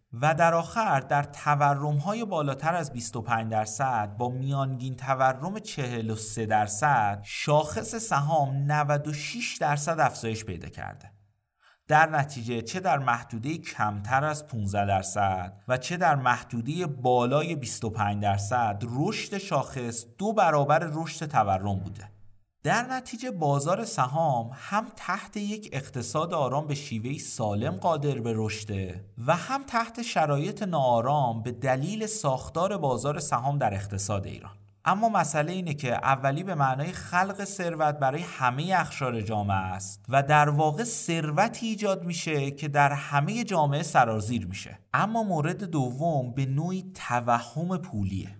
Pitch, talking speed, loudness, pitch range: 140 Hz, 130 wpm, -27 LUFS, 115-165 Hz